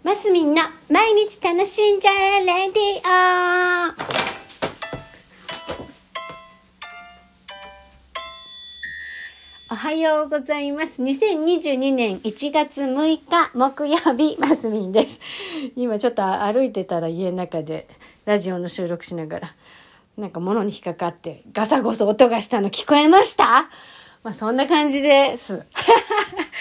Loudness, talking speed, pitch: -19 LUFS, 235 characters per minute, 270 Hz